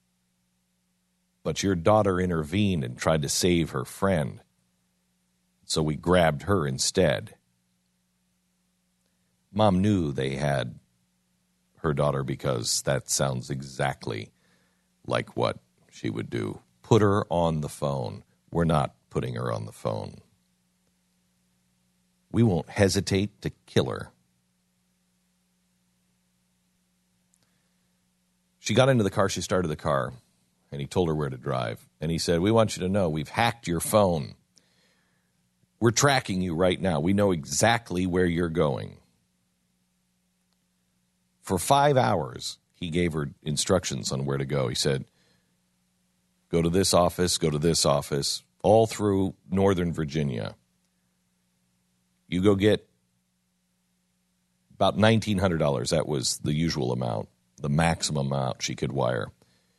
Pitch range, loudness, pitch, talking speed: 60-90 Hz, -26 LUFS, 65 Hz, 130 wpm